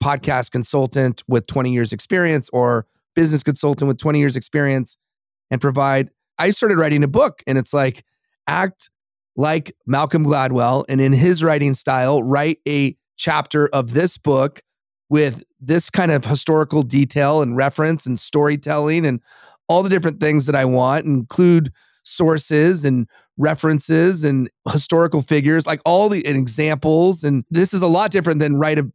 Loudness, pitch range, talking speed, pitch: -17 LUFS, 135-160 Hz, 160 wpm, 150 Hz